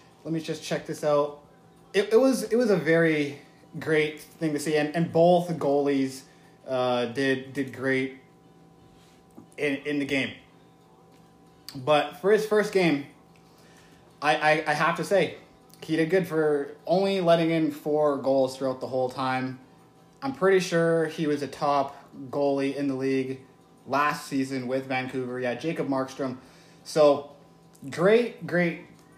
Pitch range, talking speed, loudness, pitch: 135-160 Hz, 150 wpm, -26 LUFS, 145 Hz